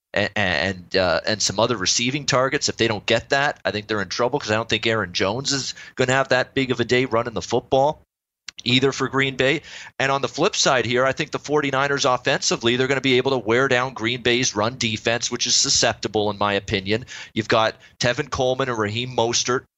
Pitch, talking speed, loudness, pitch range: 125 Hz, 230 wpm, -21 LUFS, 110-135 Hz